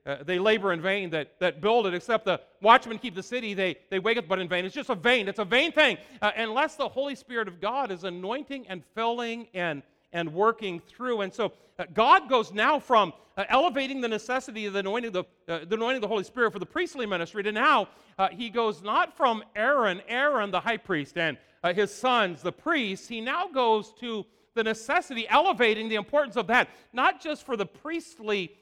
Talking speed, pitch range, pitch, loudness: 220 wpm, 190-250 Hz, 220 Hz, -27 LUFS